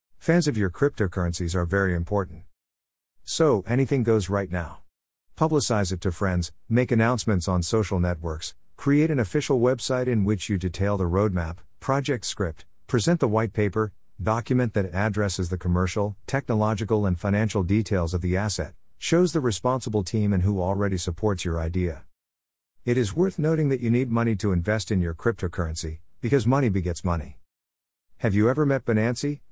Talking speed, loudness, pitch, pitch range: 165 wpm, -25 LUFS, 100 Hz, 90-120 Hz